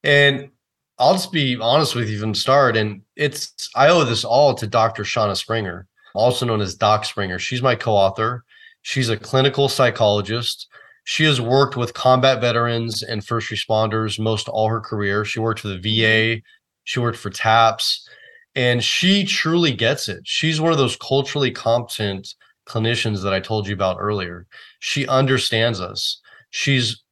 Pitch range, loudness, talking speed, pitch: 110-135 Hz, -19 LUFS, 170 wpm, 115 Hz